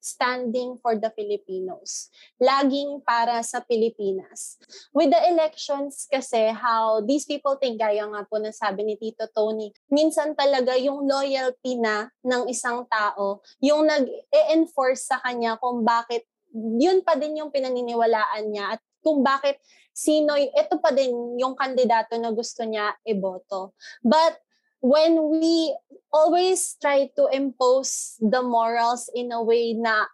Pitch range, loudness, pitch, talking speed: 230-290 Hz, -23 LUFS, 255 Hz, 140 wpm